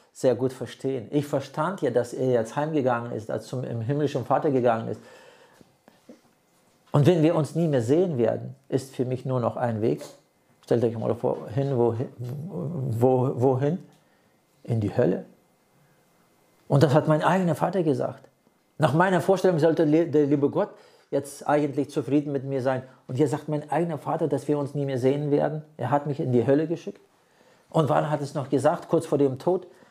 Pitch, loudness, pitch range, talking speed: 145 Hz, -25 LUFS, 130-155 Hz, 185 wpm